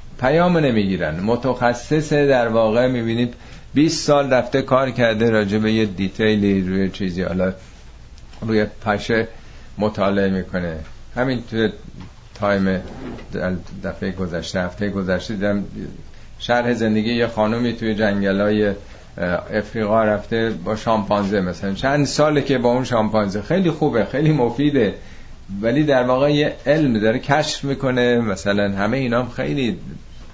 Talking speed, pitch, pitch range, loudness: 125 wpm, 110 Hz, 100-125 Hz, -19 LUFS